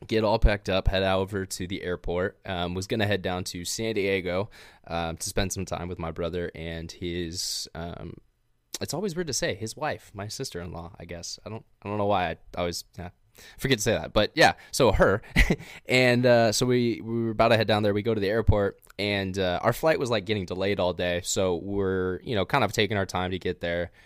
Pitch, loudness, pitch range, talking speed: 95 Hz, -26 LUFS, 90-110 Hz, 235 wpm